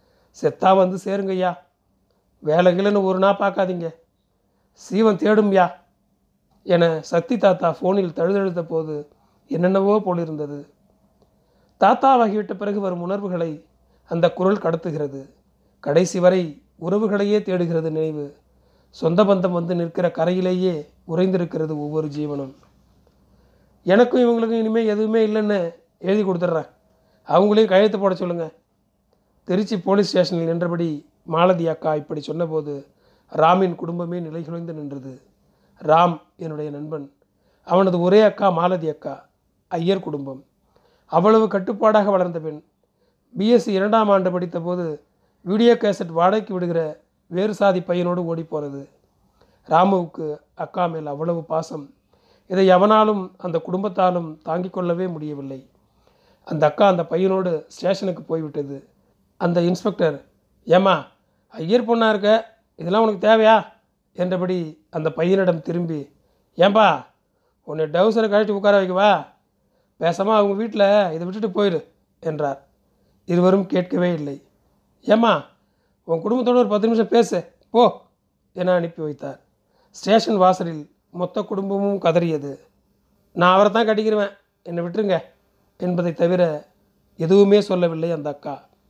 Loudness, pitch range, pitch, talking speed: -20 LUFS, 160-200 Hz, 180 Hz, 110 wpm